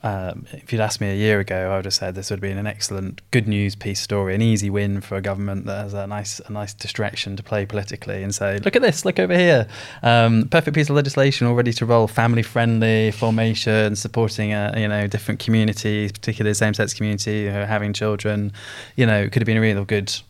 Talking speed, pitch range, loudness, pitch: 235 wpm, 100-115 Hz, -20 LUFS, 105 Hz